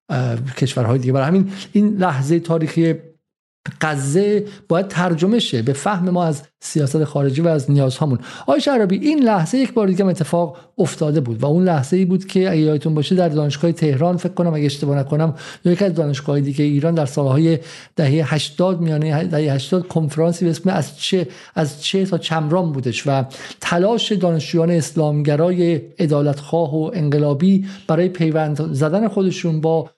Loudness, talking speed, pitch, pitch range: -18 LUFS, 160 wpm, 160 Hz, 150-180 Hz